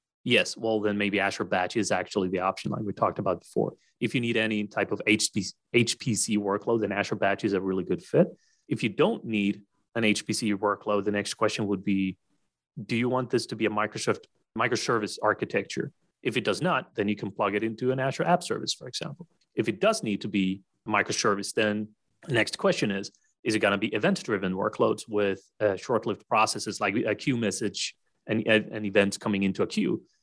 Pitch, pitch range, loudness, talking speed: 105 Hz, 100-110 Hz, -27 LUFS, 210 wpm